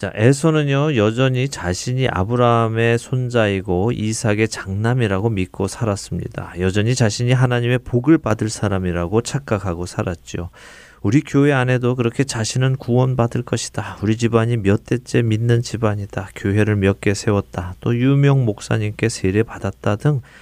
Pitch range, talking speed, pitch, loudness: 100-125 Hz, 340 characters per minute, 115 Hz, -19 LUFS